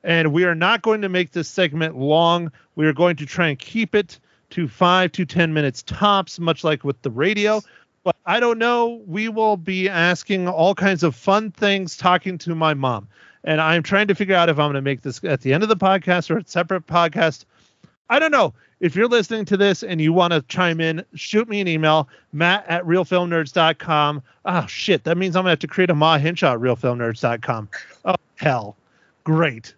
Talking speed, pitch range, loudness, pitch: 215 wpm, 155-195 Hz, -19 LUFS, 170 Hz